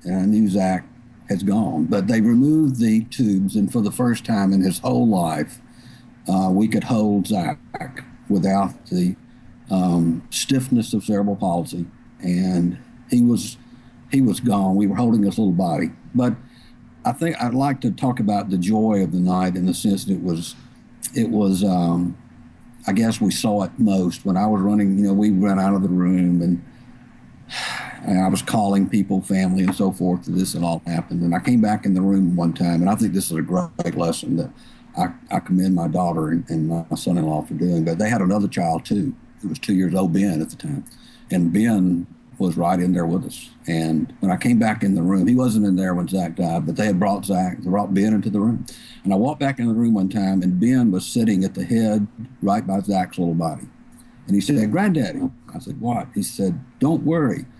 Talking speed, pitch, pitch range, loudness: 220 wpm, 95 Hz, 90-115 Hz, -20 LUFS